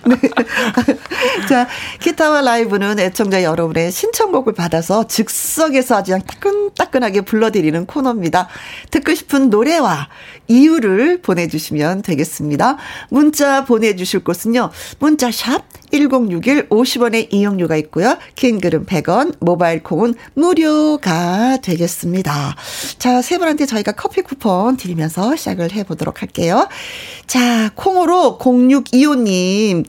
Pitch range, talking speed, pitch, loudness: 185-285 Hz, 270 characters per minute, 235 Hz, -15 LUFS